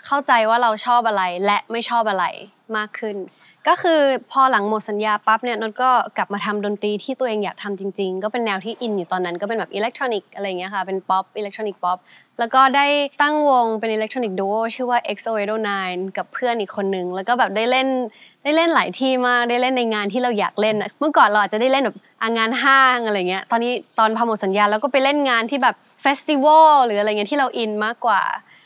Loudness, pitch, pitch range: -19 LUFS, 225 Hz, 205-255 Hz